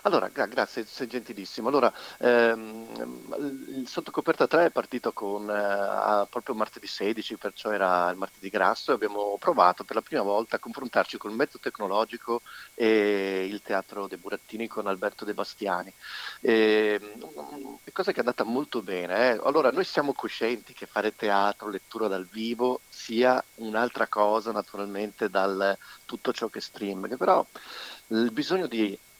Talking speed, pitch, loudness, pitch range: 155 wpm, 105 Hz, -28 LUFS, 100-115 Hz